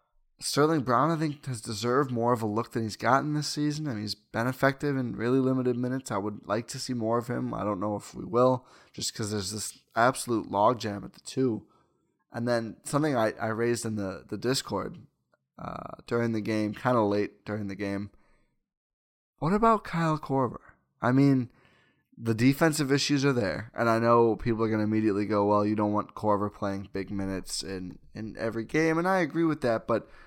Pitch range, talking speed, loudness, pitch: 105-135 Hz, 210 wpm, -28 LUFS, 115 Hz